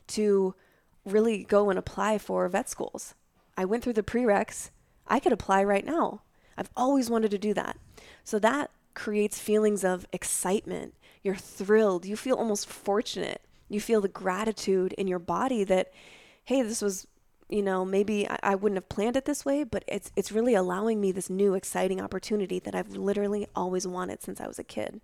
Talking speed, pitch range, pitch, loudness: 185 wpm, 190-220 Hz, 205 Hz, -28 LUFS